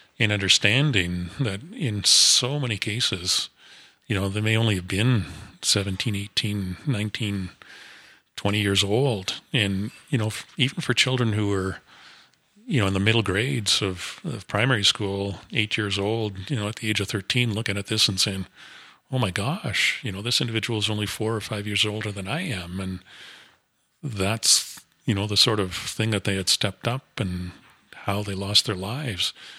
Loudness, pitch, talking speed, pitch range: -23 LUFS, 105 Hz, 185 wpm, 100-120 Hz